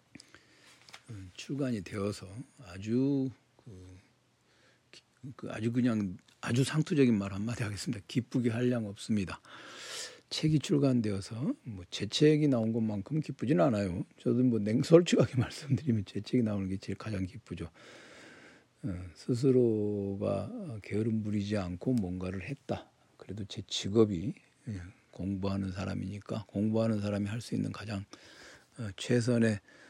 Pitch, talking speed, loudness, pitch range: 110 Hz, 275 characters per minute, -32 LUFS, 100-125 Hz